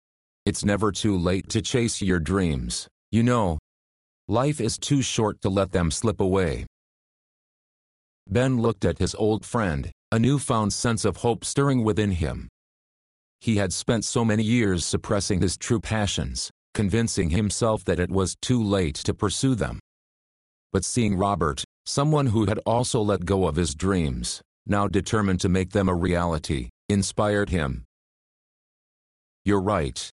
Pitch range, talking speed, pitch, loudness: 85-110 Hz, 150 wpm, 100 Hz, -24 LUFS